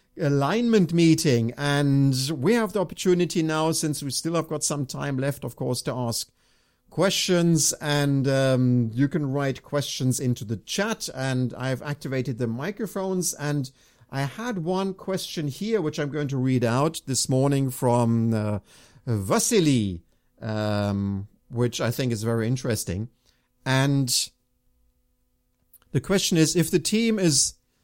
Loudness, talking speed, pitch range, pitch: -24 LUFS, 145 wpm, 120-165 Hz, 140 Hz